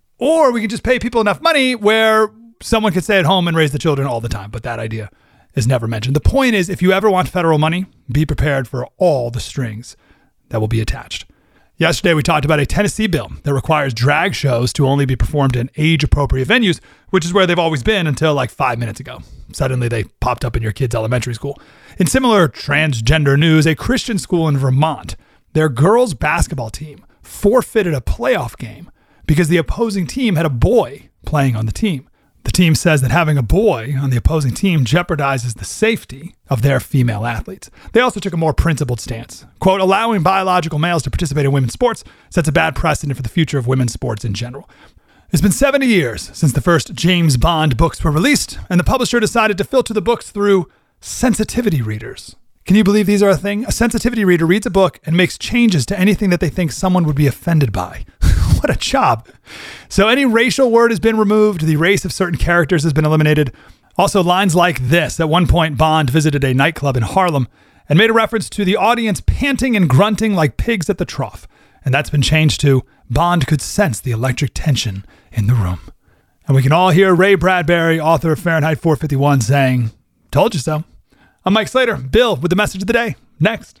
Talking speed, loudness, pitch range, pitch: 210 wpm, -15 LUFS, 135-195 Hz, 160 Hz